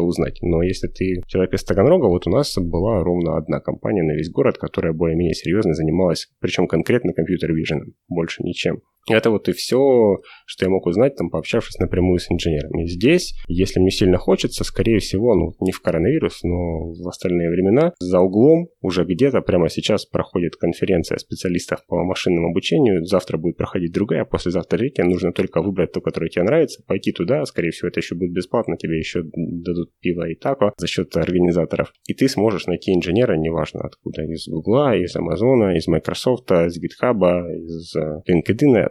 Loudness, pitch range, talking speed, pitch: -20 LUFS, 85-95 Hz, 175 wpm, 90 Hz